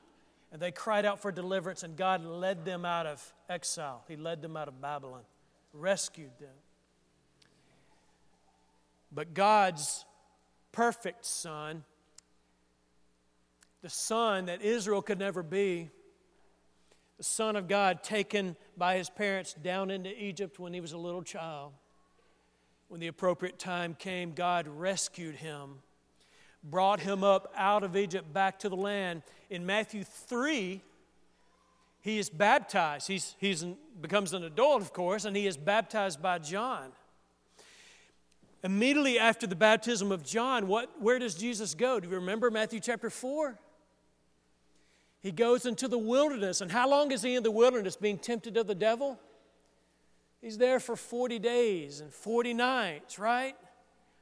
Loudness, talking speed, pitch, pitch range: -32 LUFS, 145 wpm, 190 Hz, 155-220 Hz